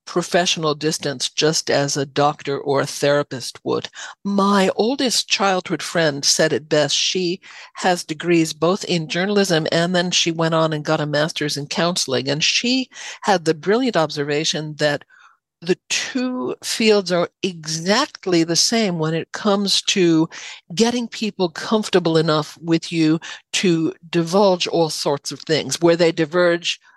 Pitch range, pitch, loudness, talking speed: 155-190 Hz, 170 Hz, -19 LUFS, 150 wpm